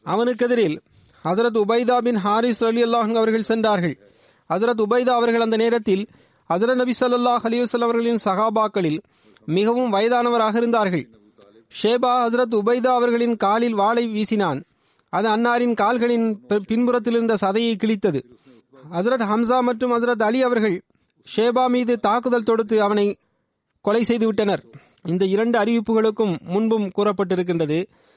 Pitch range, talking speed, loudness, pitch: 205-240 Hz, 115 wpm, -20 LUFS, 225 Hz